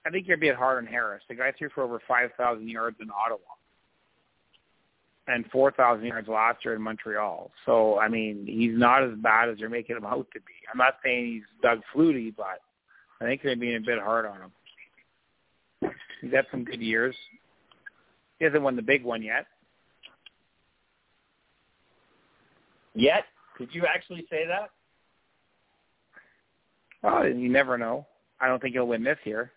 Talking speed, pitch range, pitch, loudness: 175 wpm, 115-135 Hz, 120 Hz, -26 LUFS